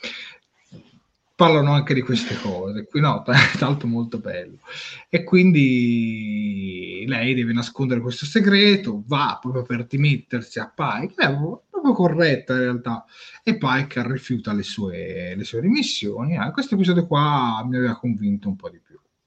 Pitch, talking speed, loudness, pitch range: 130 Hz, 160 wpm, -21 LUFS, 120-170 Hz